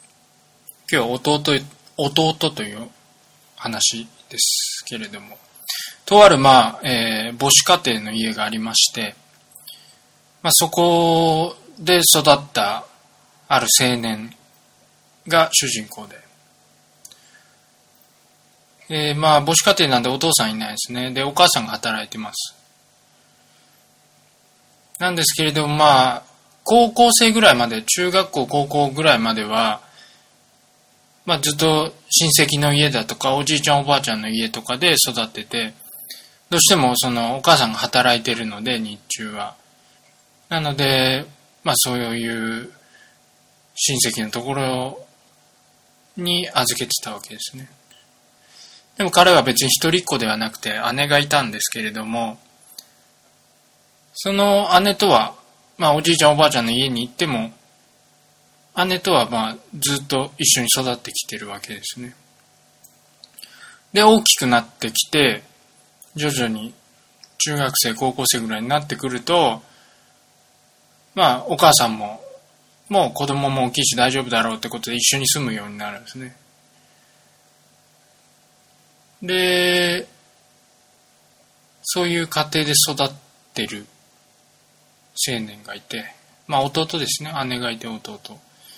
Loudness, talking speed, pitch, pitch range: -17 LUFS, 245 characters per minute, 135 Hz, 120-160 Hz